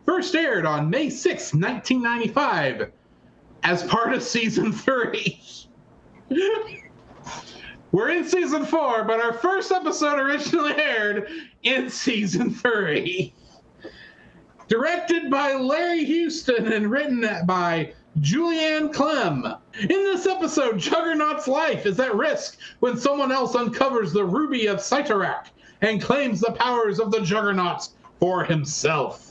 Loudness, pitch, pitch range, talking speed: -23 LUFS, 260 Hz, 215-310 Hz, 120 wpm